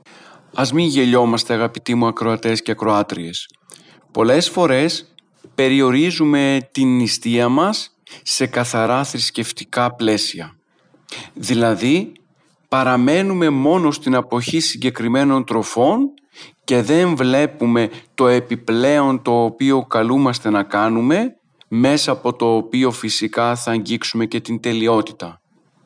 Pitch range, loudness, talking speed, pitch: 115-135 Hz, -17 LUFS, 105 wpm, 125 Hz